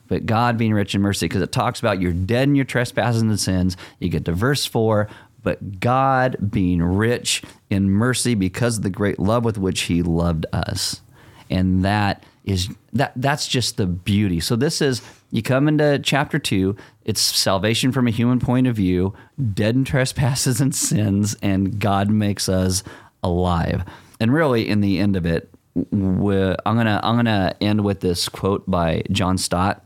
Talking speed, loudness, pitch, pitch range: 185 wpm, -20 LUFS, 105 Hz, 95-120 Hz